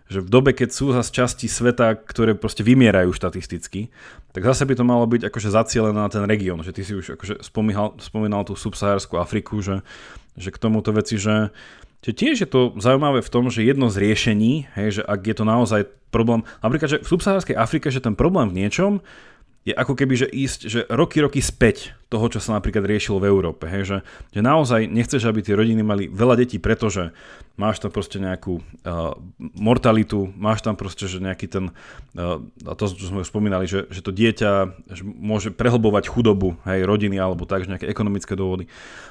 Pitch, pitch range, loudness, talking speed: 105 Hz, 95-120 Hz, -21 LUFS, 200 wpm